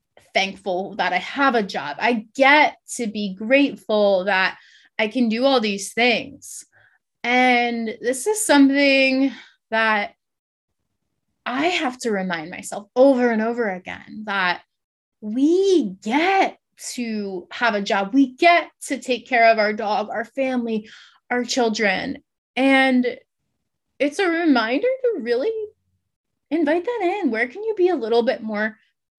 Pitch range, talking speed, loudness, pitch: 220-280 Hz, 140 wpm, -20 LUFS, 245 Hz